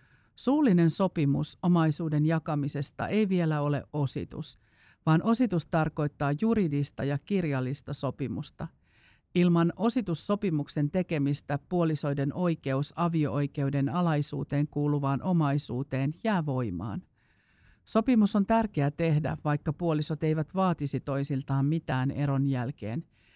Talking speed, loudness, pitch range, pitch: 100 wpm, -29 LUFS, 140-170 Hz, 150 Hz